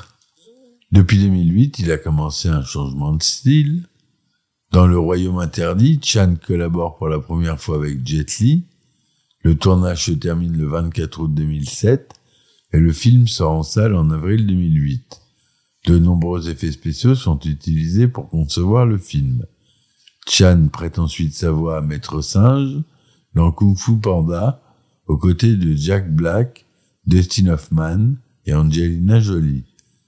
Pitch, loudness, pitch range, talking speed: 85 Hz, -17 LUFS, 80-115 Hz, 140 wpm